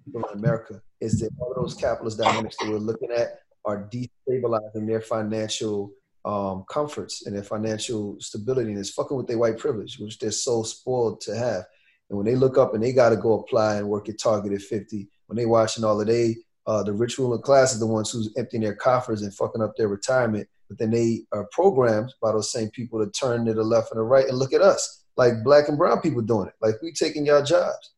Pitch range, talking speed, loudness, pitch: 105-125 Hz, 230 wpm, -24 LUFS, 110 Hz